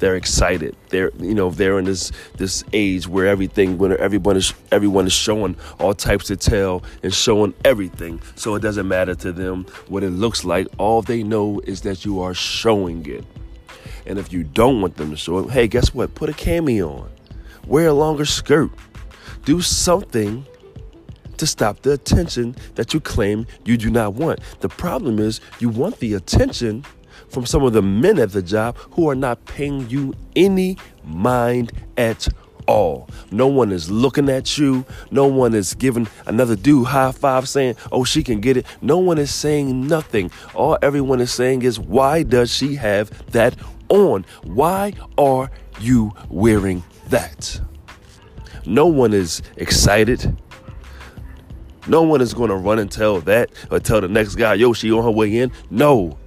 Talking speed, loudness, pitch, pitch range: 180 wpm, -18 LUFS, 110 Hz, 95-130 Hz